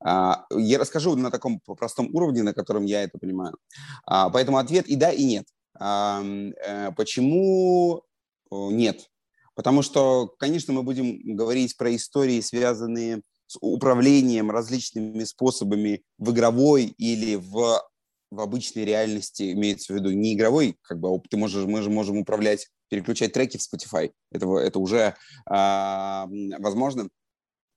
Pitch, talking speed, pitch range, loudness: 110 Hz, 140 wpm, 100-130 Hz, -24 LUFS